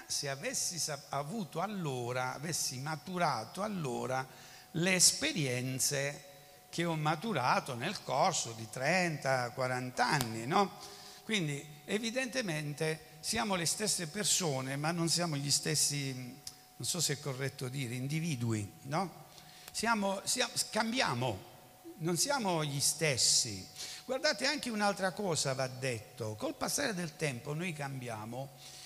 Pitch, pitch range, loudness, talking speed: 150 Hz, 130-180 Hz, -33 LUFS, 115 wpm